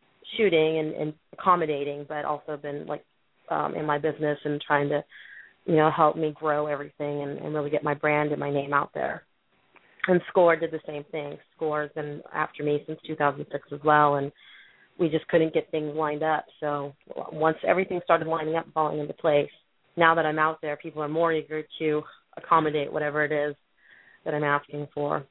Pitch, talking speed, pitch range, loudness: 150 Hz, 195 wpm, 145-160 Hz, -26 LUFS